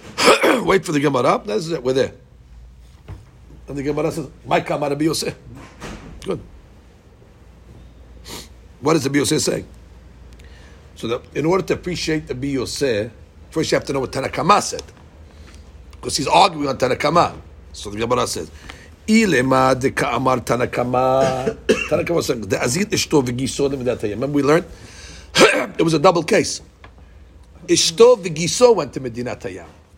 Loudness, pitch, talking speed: -18 LUFS, 120 Hz, 120 wpm